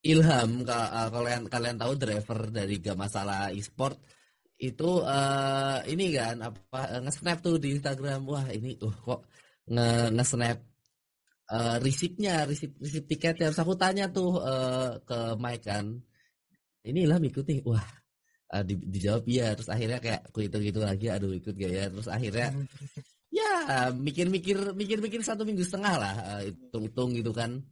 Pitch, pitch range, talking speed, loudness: 125 Hz, 110-155 Hz, 145 wpm, -30 LUFS